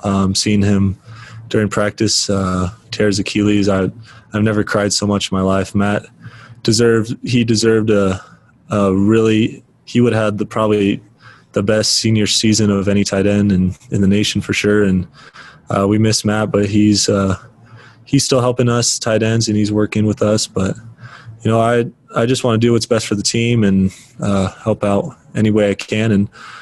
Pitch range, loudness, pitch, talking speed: 100-115 Hz, -15 LUFS, 105 Hz, 195 wpm